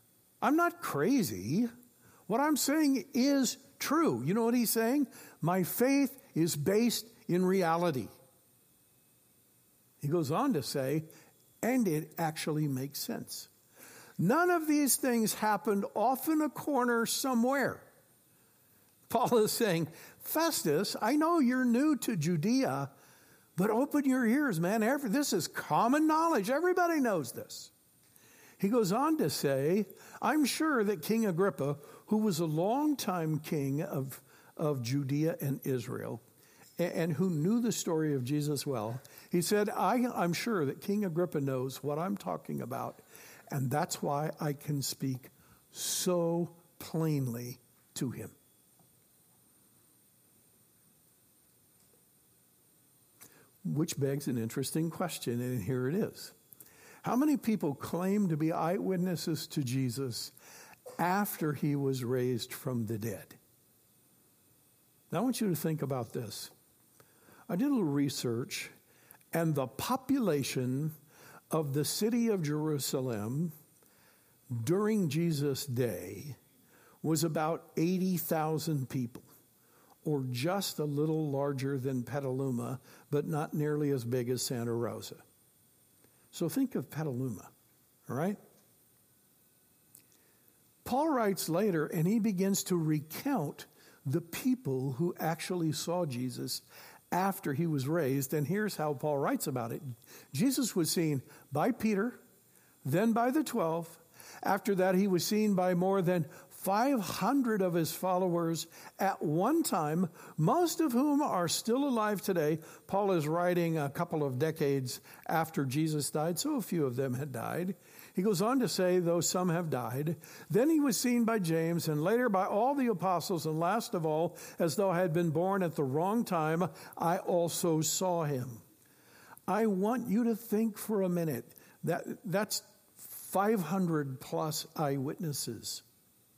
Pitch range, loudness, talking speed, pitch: 145-215 Hz, -32 LUFS, 135 wpm, 170 Hz